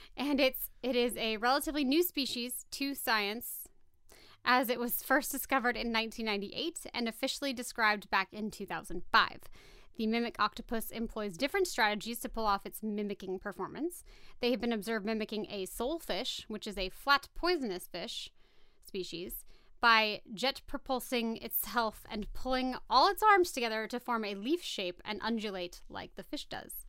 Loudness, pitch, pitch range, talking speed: -33 LUFS, 230 Hz, 210-265 Hz, 160 wpm